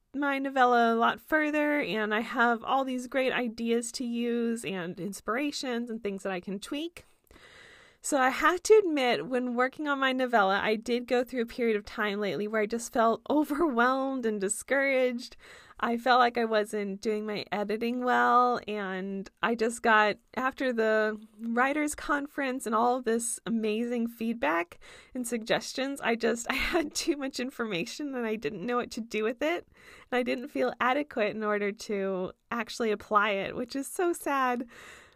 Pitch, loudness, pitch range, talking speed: 235 Hz, -29 LUFS, 215-260 Hz, 175 wpm